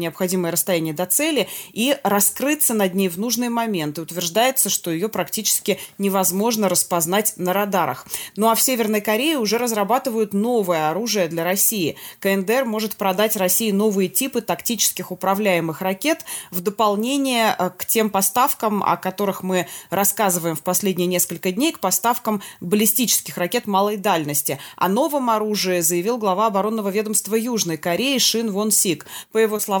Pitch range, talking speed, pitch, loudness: 180-225 Hz, 150 wpm, 200 Hz, -20 LUFS